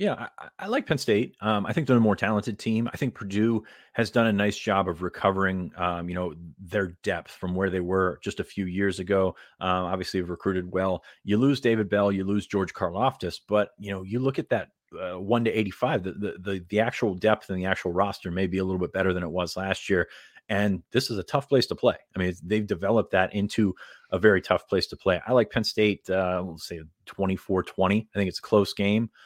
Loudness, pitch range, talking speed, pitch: -26 LUFS, 90-105 Hz, 240 wpm, 100 Hz